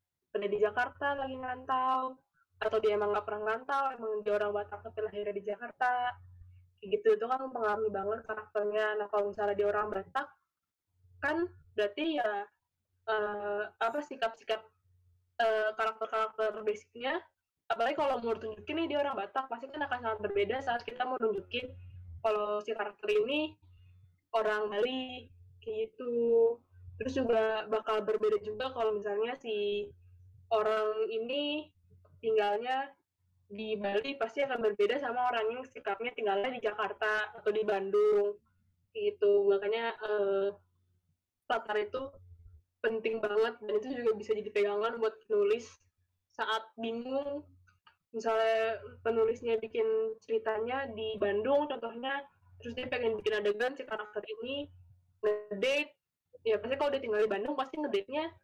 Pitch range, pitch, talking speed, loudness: 205-255 Hz, 220 Hz, 140 wpm, -33 LUFS